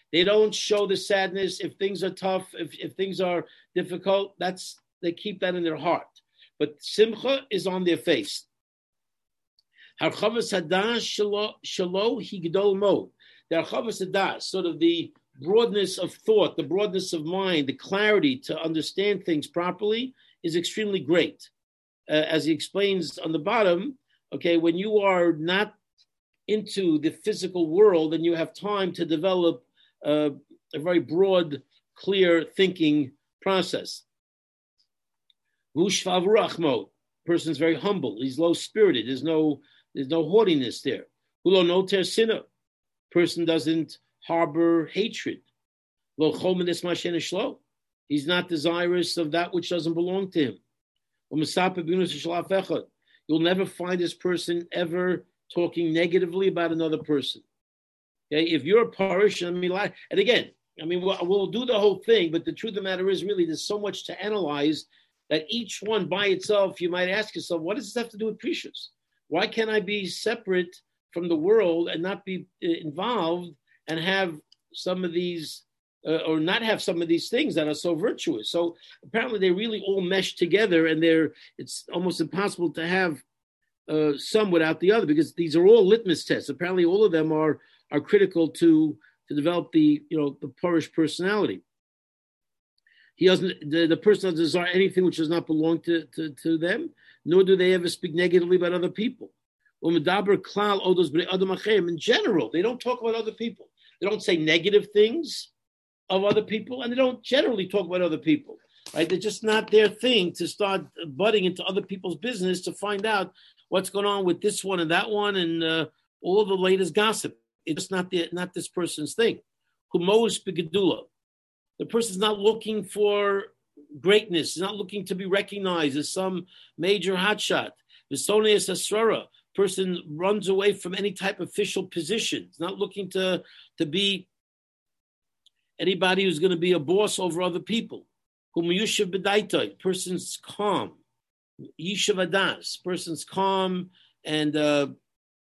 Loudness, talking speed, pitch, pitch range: -25 LUFS, 155 wpm, 185 Hz, 165-205 Hz